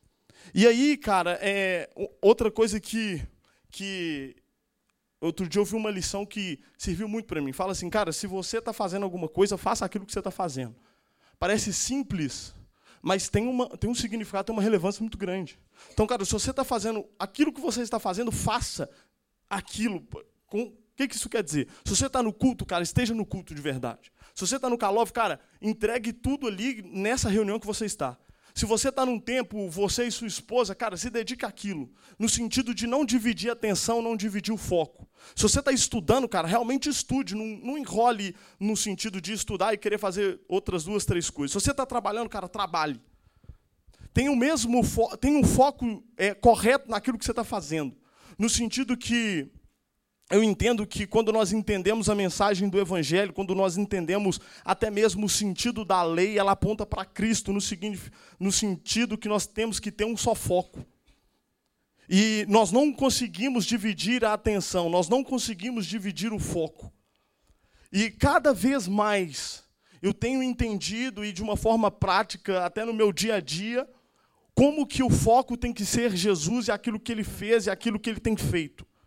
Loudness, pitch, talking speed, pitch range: -27 LUFS, 215 Hz, 185 wpm, 195-235 Hz